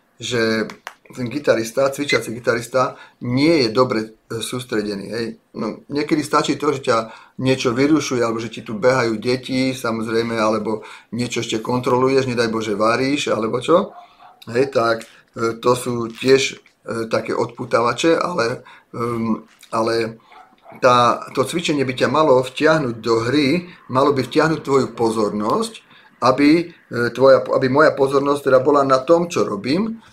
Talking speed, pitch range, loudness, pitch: 125 wpm, 115-140 Hz, -19 LUFS, 125 Hz